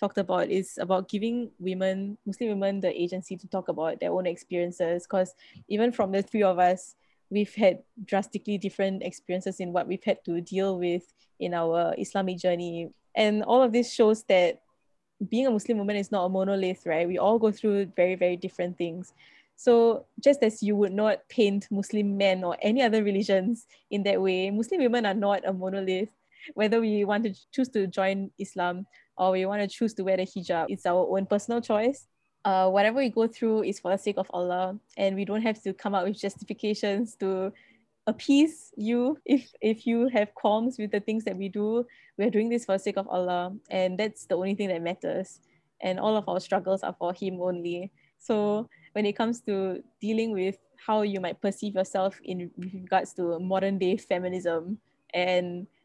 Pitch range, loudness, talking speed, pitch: 185-215 Hz, -27 LUFS, 200 wpm, 195 Hz